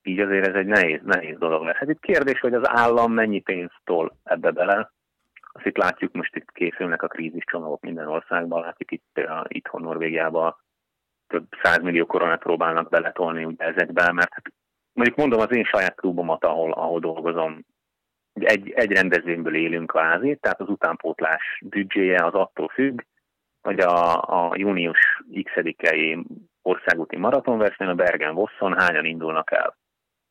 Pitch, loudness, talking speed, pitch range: 85 Hz, -22 LUFS, 155 wpm, 80-100 Hz